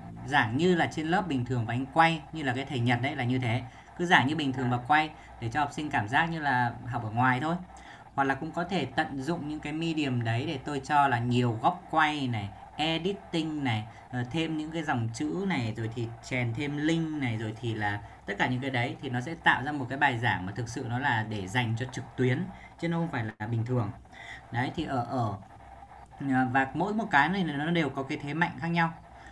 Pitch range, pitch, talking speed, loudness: 120-155 Hz, 135 Hz, 250 wpm, -29 LUFS